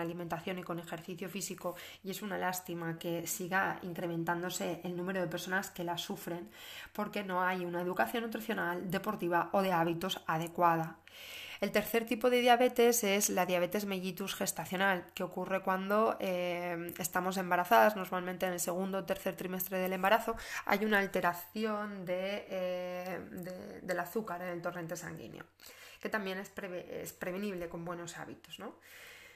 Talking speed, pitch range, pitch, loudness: 155 wpm, 175-195 Hz, 185 Hz, -34 LUFS